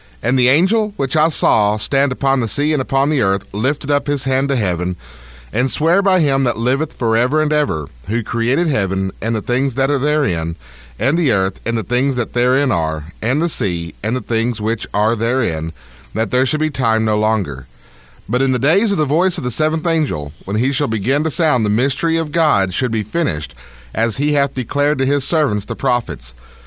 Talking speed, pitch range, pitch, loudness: 220 wpm, 100-145 Hz, 125 Hz, -17 LUFS